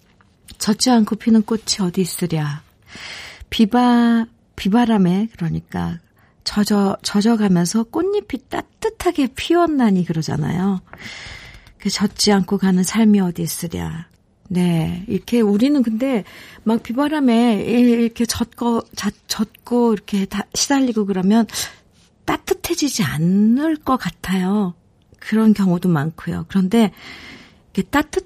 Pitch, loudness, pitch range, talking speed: 210 Hz, -18 LUFS, 185-235 Hz, 250 characters per minute